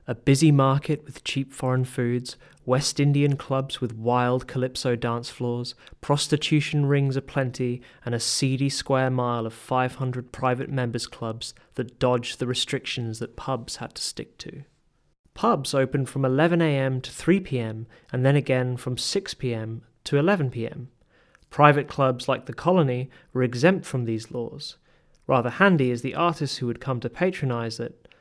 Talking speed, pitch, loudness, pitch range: 155 wpm, 130 Hz, -25 LUFS, 125-145 Hz